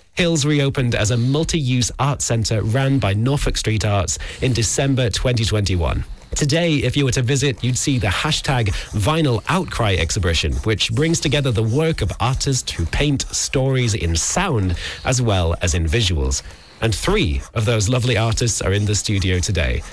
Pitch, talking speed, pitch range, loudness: 115 Hz, 170 wpm, 95-135 Hz, -19 LUFS